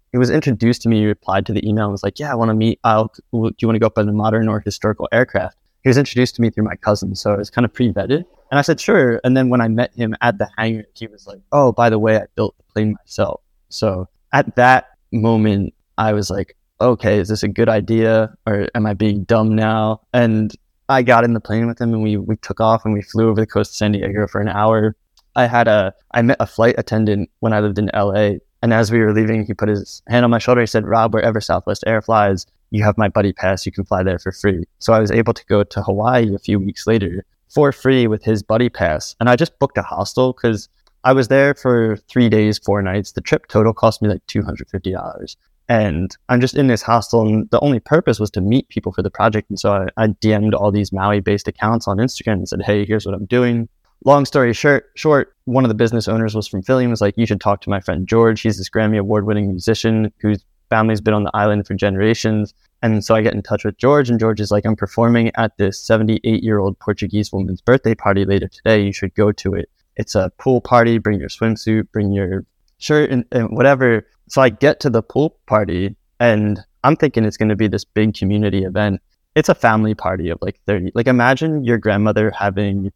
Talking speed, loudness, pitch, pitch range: 245 wpm, -17 LUFS, 110 Hz, 100-115 Hz